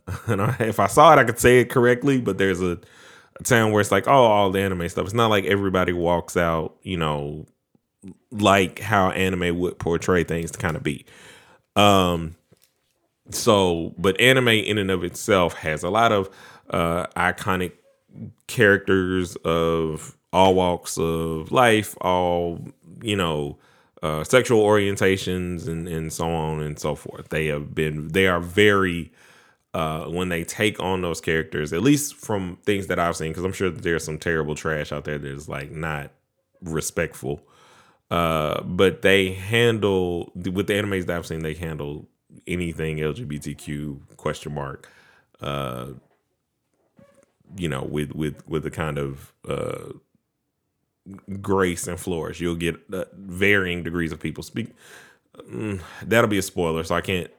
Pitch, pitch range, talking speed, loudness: 90 Hz, 80-100 Hz, 160 wpm, -22 LUFS